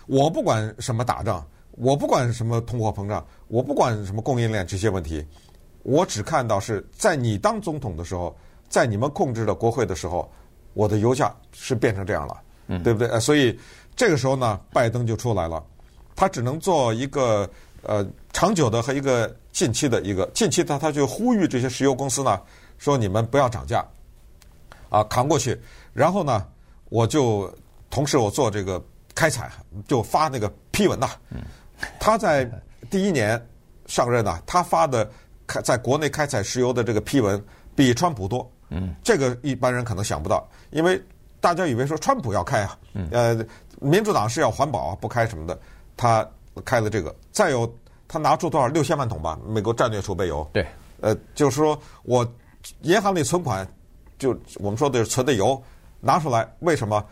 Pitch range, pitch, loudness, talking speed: 100-135 Hz, 115 Hz, -23 LUFS, 270 characters per minute